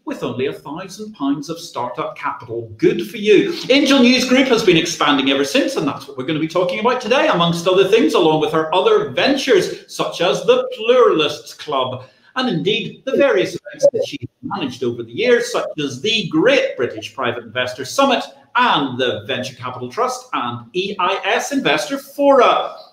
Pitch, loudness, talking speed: 210 Hz, -17 LUFS, 180 wpm